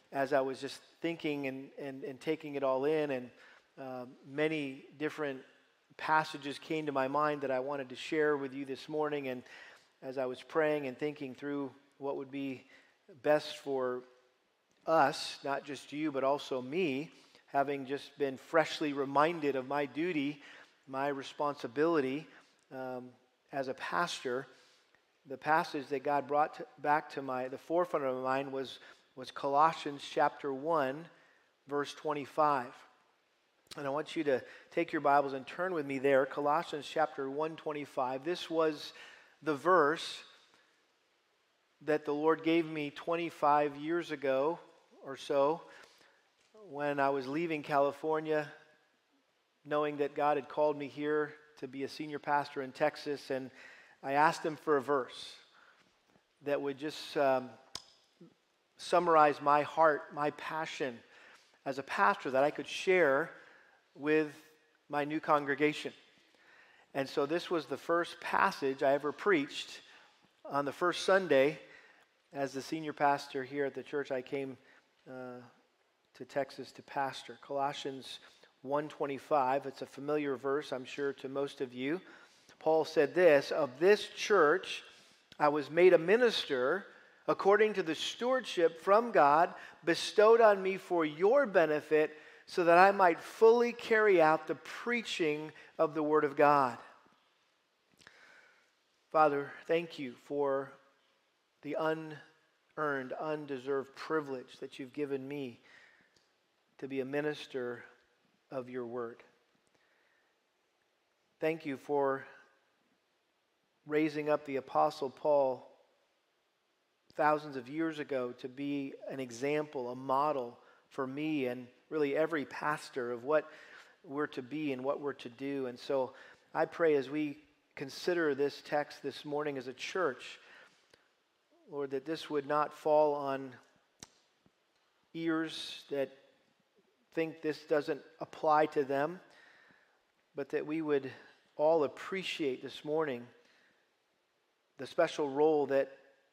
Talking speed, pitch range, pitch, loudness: 135 wpm, 135-155 Hz, 145 Hz, -33 LUFS